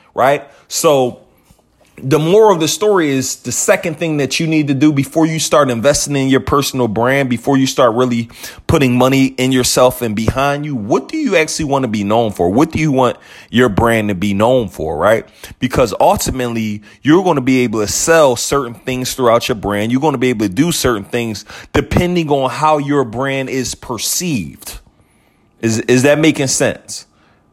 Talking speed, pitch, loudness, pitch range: 195 wpm, 130 Hz, -14 LUFS, 115-145 Hz